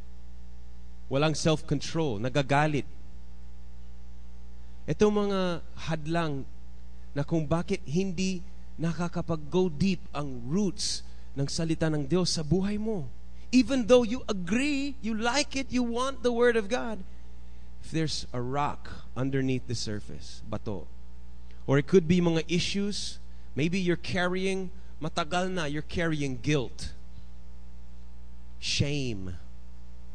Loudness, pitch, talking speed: -29 LUFS, 145 Hz, 115 wpm